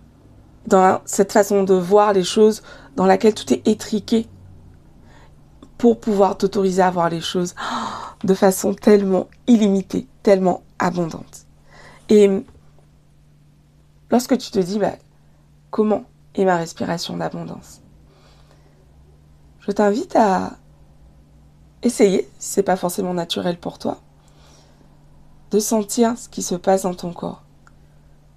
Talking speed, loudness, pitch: 125 wpm, -19 LUFS, 185 Hz